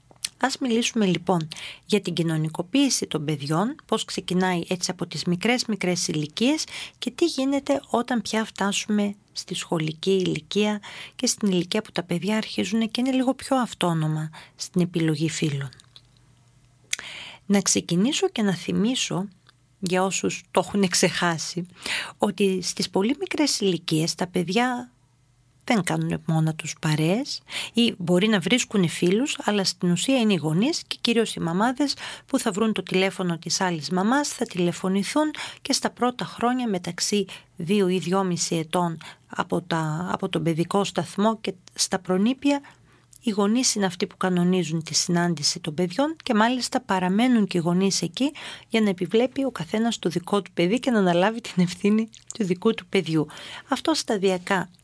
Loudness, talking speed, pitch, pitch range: -24 LUFS, 155 wpm, 190 Hz, 175-225 Hz